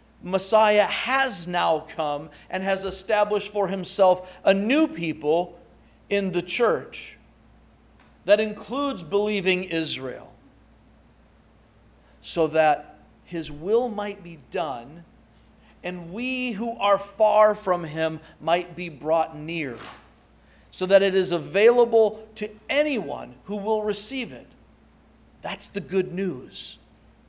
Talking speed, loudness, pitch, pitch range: 115 wpm, -24 LUFS, 195 Hz, 170-215 Hz